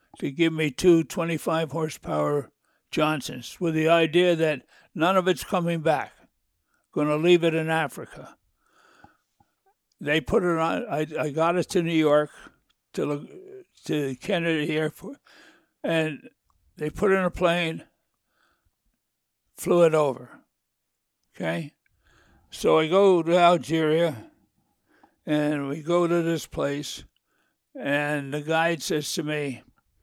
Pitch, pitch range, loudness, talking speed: 160 Hz, 150-170 Hz, -24 LUFS, 130 wpm